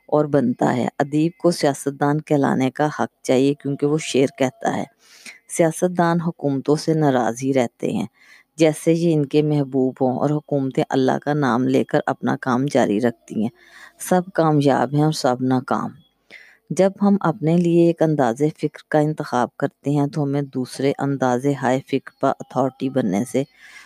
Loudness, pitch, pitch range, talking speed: -20 LUFS, 145 Hz, 130-155 Hz, 170 wpm